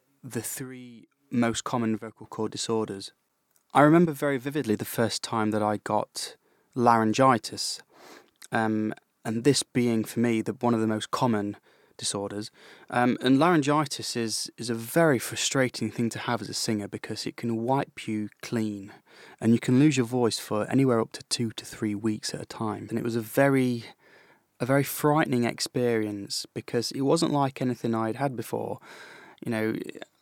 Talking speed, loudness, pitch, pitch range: 175 wpm, -27 LUFS, 115 Hz, 110-130 Hz